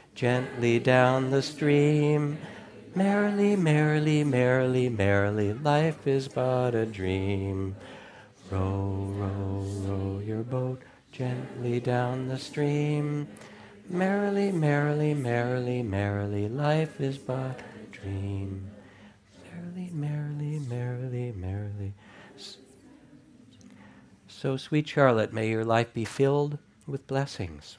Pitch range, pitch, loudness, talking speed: 100-145 Hz, 125 Hz, -28 LUFS, 95 wpm